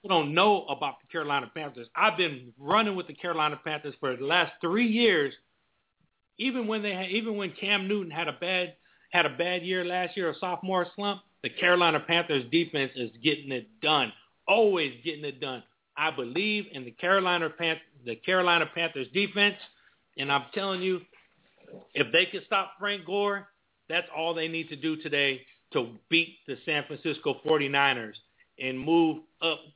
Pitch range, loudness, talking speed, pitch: 150-190 Hz, -27 LUFS, 175 wpm, 170 Hz